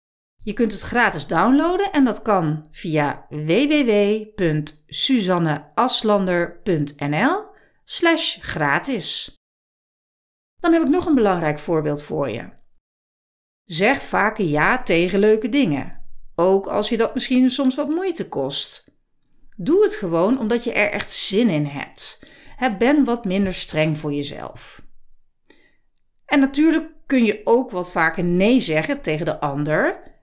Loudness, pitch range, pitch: -20 LUFS, 165-265 Hz, 210 Hz